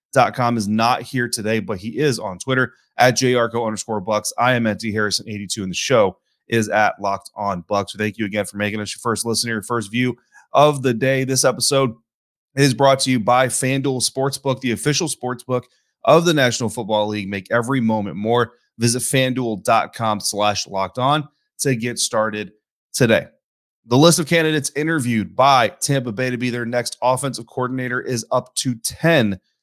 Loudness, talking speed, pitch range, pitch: -19 LUFS, 185 wpm, 110-130 Hz, 120 Hz